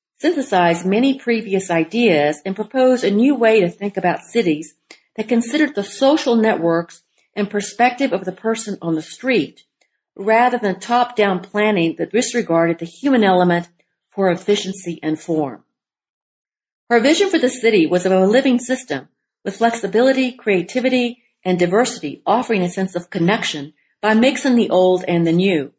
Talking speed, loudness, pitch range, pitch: 155 wpm, -17 LUFS, 175-240 Hz, 205 Hz